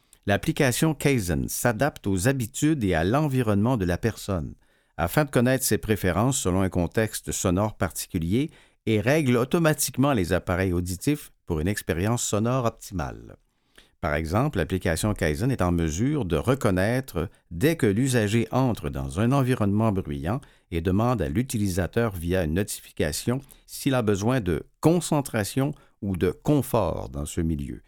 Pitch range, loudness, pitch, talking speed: 90-130 Hz, -25 LUFS, 110 Hz, 145 wpm